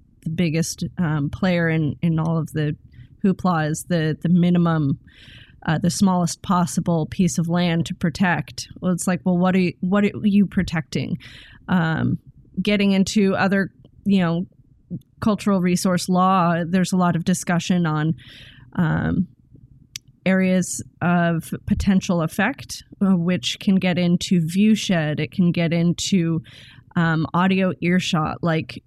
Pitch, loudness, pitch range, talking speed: 175 Hz, -21 LUFS, 155-185 Hz, 140 wpm